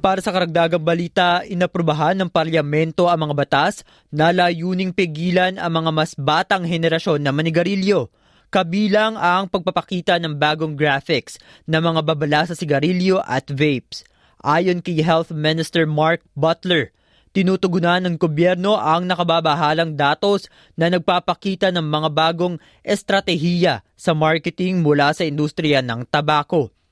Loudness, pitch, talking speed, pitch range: -19 LUFS, 170 Hz, 130 wpm, 155-180 Hz